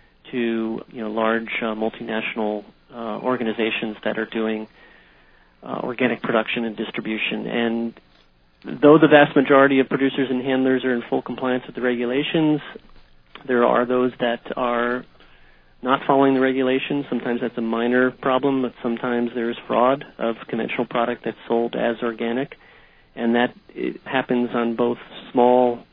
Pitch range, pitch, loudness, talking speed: 115-130 Hz, 120 Hz, -21 LUFS, 150 wpm